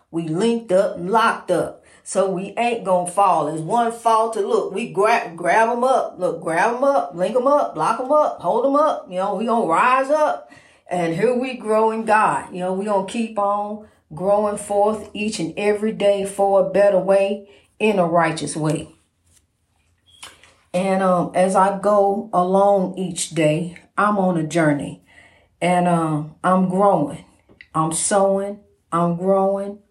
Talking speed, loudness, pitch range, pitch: 170 wpm, -19 LUFS, 175-215 Hz, 195 Hz